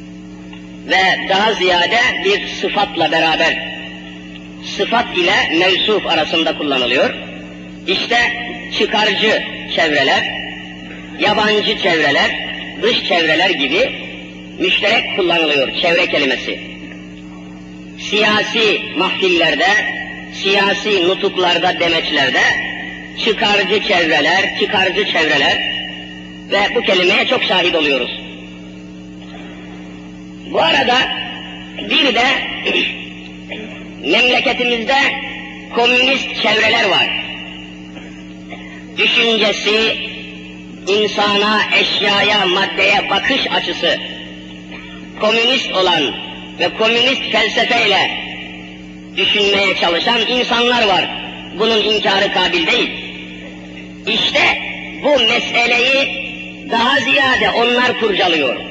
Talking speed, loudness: 75 wpm, -13 LUFS